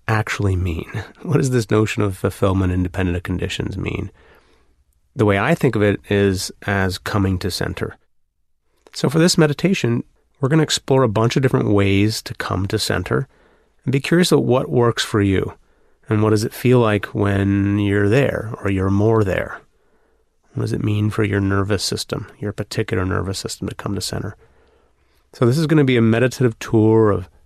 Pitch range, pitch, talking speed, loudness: 100-120 Hz, 105 Hz, 190 wpm, -19 LUFS